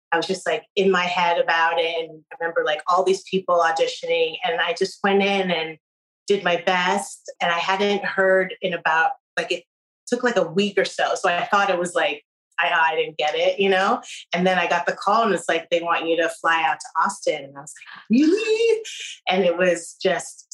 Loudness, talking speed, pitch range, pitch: -21 LUFS, 230 wpm, 170-200 Hz, 180 Hz